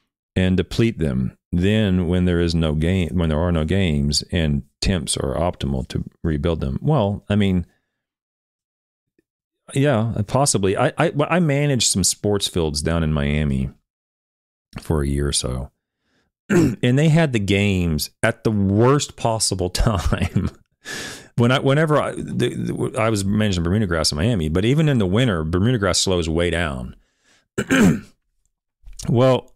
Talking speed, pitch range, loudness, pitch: 150 wpm, 80-115 Hz, -20 LUFS, 95 Hz